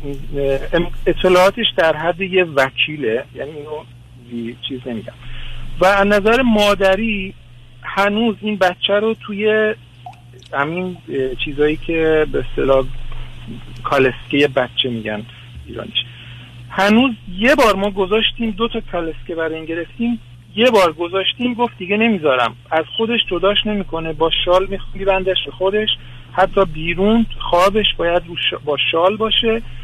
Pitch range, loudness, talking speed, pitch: 125-200 Hz, -17 LUFS, 120 wpm, 170 Hz